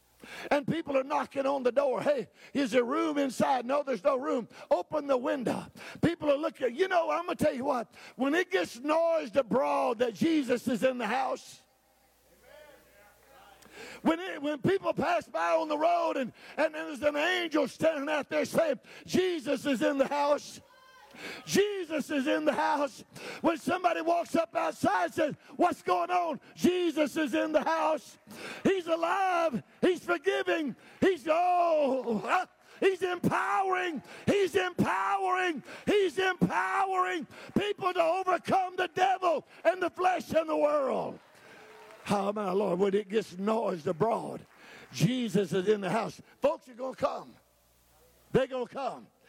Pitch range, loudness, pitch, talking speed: 265-350 Hz, -30 LUFS, 305 Hz, 155 wpm